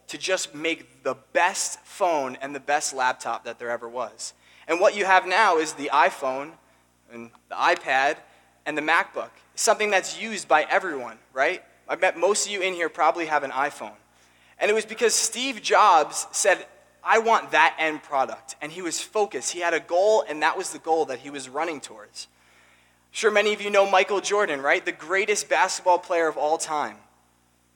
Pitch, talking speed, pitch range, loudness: 160 Hz, 195 wpm, 135-190 Hz, -23 LUFS